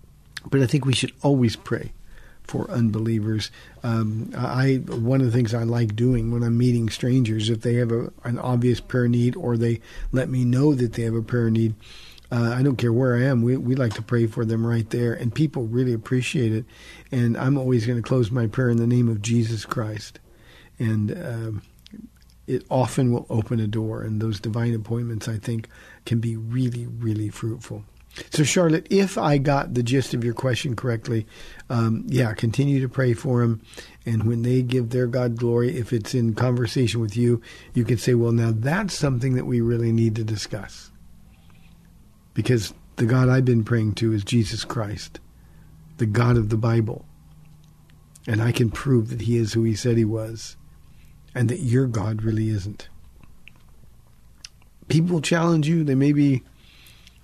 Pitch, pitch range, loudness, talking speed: 120 Hz, 115-130 Hz, -23 LUFS, 185 wpm